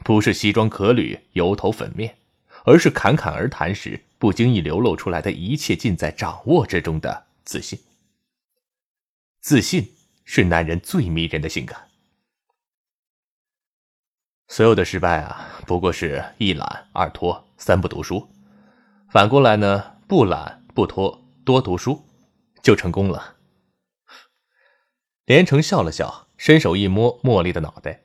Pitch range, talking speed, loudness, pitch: 85-140 Hz, 200 characters per minute, -19 LUFS, 105 Hz